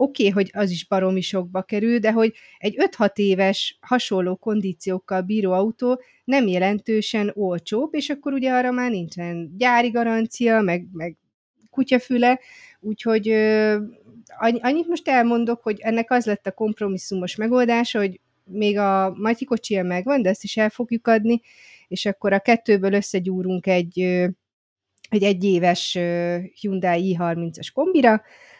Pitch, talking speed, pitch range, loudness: 210 Hz, 135 wpm, 190-235 Hz, -21 LUFS